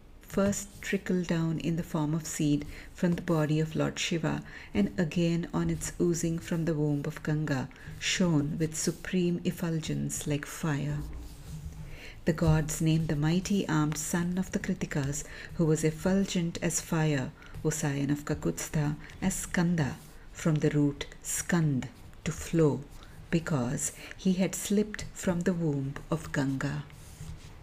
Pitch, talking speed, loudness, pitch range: 160 Hz, 140 wpm, -30 LUFS, 150-175 Hz